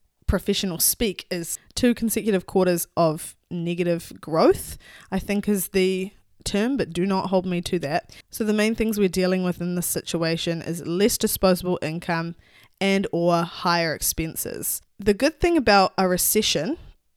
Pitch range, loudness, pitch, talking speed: 170-205 Hz, -23 LUFS, 185 Hz, 155 wpm